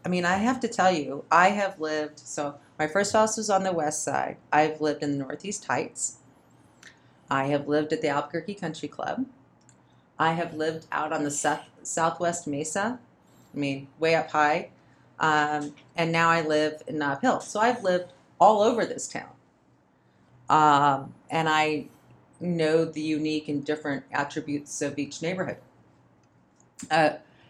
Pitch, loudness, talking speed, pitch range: 155 Hz, -26 LUFS, 165 wpm, 145-170 Hz